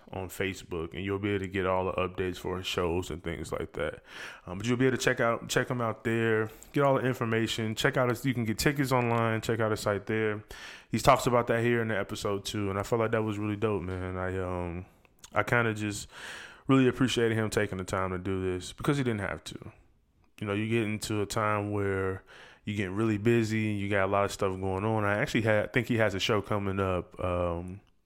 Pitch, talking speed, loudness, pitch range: 105 Hz, 250 wpm, -30 LUFS, 95-115 Hz